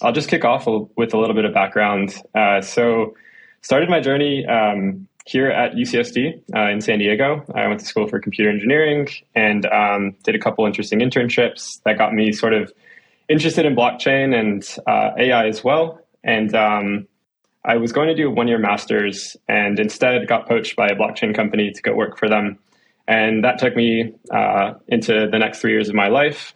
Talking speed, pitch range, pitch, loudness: 195 wpm, 105-125 Hz, 110 Hz, -18 LUFS